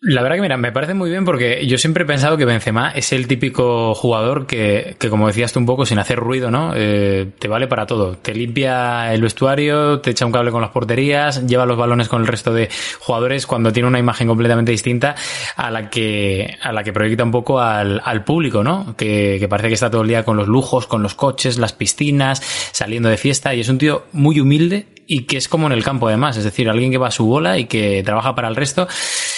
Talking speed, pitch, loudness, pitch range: 245 wpm, 125 Hz, -16 LUFS, 115-135 Hz